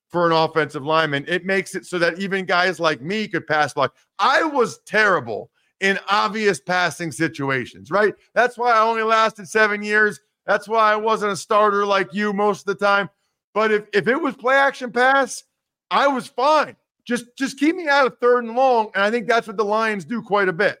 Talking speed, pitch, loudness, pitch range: 215 wpm, 210 Hz, -19 LUFS, 180-230 Hz